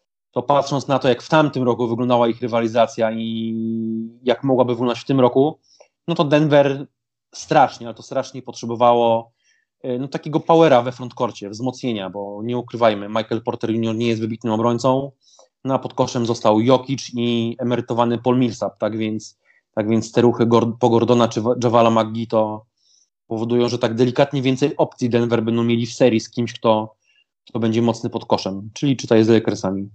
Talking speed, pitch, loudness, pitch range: 175 wpm, 120 Hz, -19 LUFS, 115-125 Hz